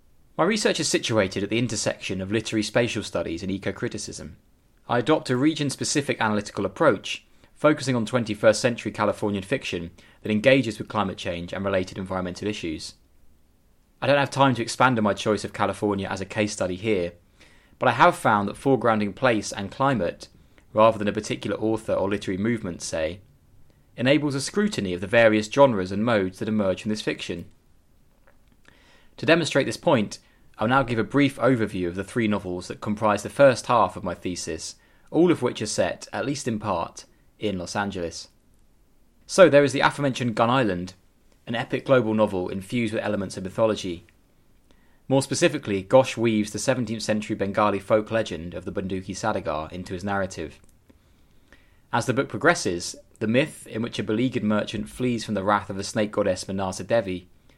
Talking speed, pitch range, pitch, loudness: 180 wpm, 95-120 Hz, 105 Hz, -24 LUFS